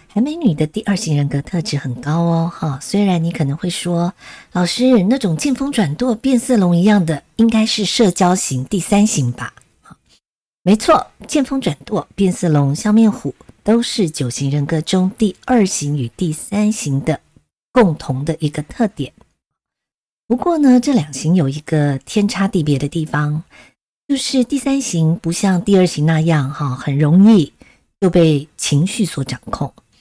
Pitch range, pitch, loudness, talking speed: 150-215 Hz, 175 Hz, -16 LUFS, 240 characters per minute